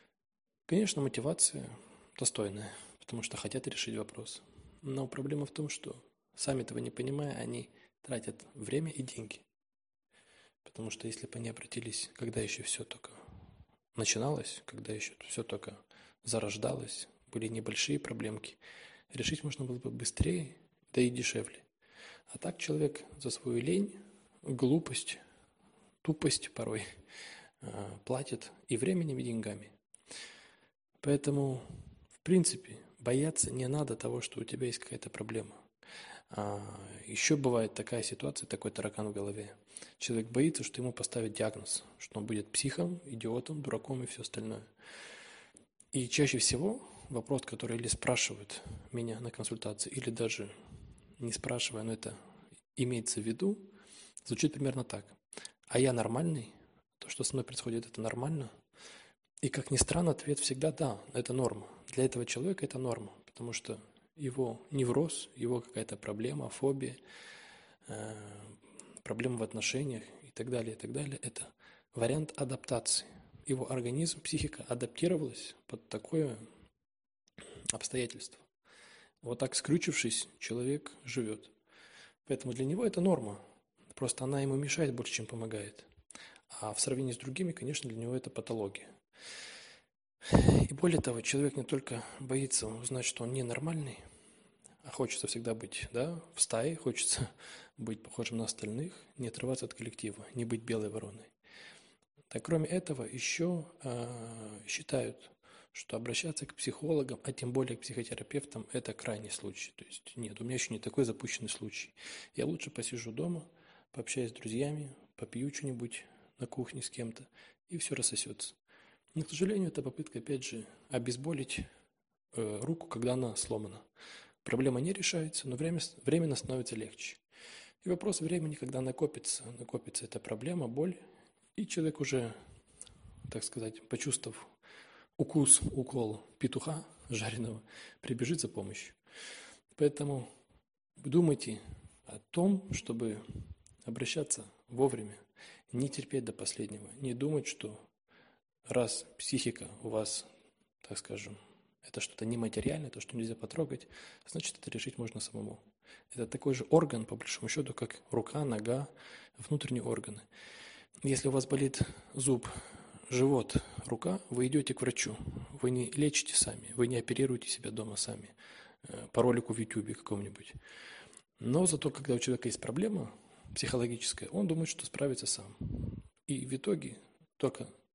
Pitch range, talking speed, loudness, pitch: 110-145 Hz, 135 wpm, -36 LUFS, 125 Hz